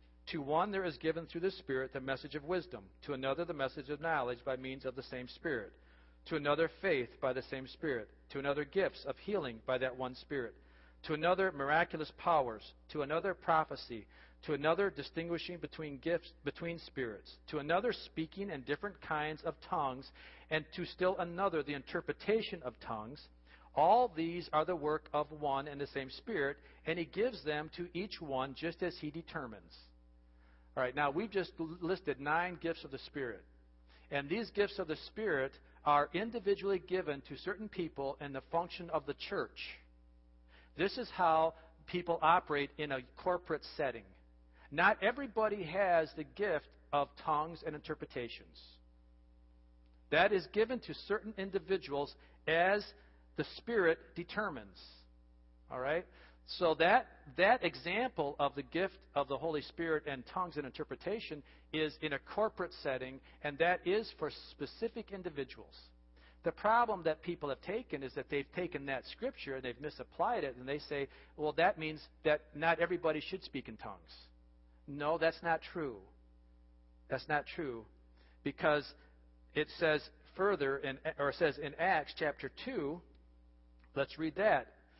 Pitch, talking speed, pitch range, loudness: 150 Hz, 160 wpm, 125-170 Hz, -37 LUFS